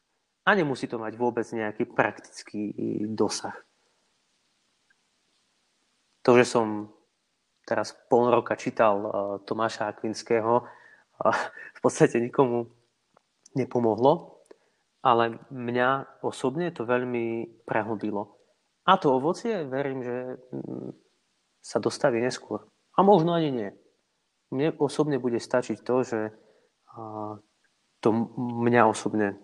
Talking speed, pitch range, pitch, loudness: 100 wpm, 110-130 Hz, 120 Hz, -26 LUFS